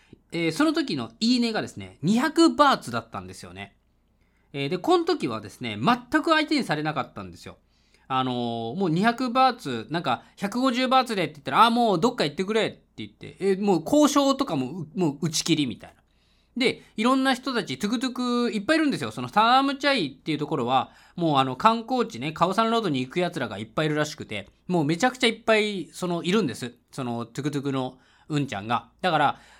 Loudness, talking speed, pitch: -24 LUFS, 440 characters per minute, 175 Hz